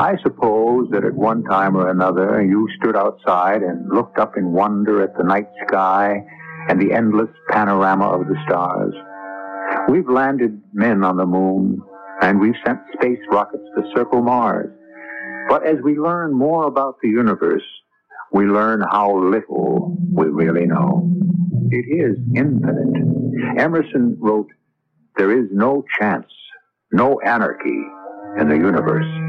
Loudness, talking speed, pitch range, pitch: -17 LUFS, 145 wpm, 95-135 Hz, 105 Hz